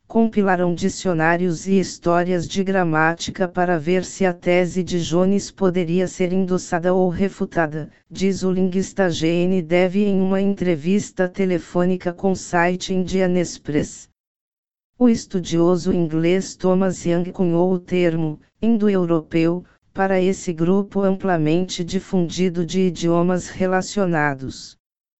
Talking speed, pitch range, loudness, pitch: 115 wpm, 175-190 Hz, -20 LUFS, 180 Hz